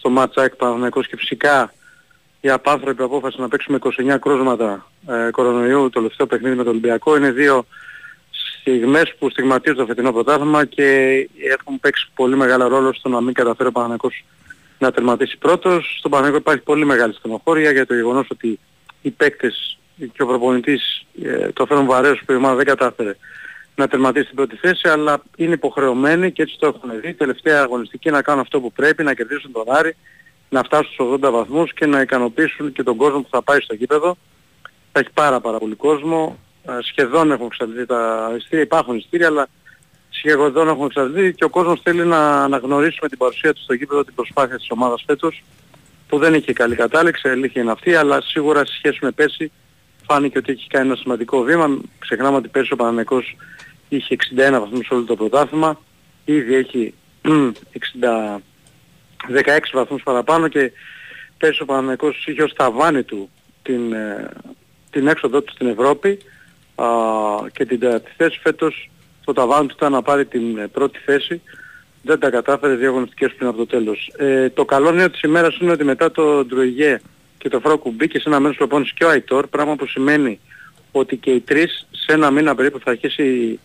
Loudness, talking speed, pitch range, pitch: -17 LUFS, 180 wpm, 125-150 Hz, 135 Hz